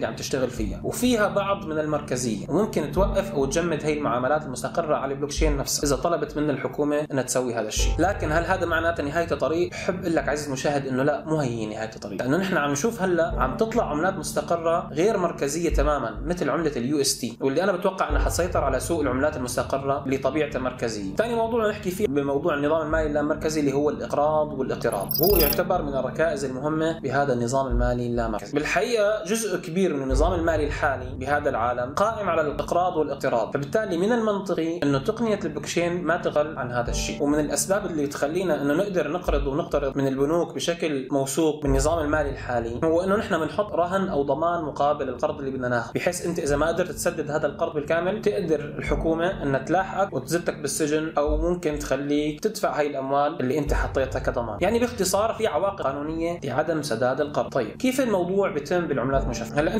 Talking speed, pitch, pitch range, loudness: 180 wpm, 150 Hz, 135-175 Hz, -25 LUFS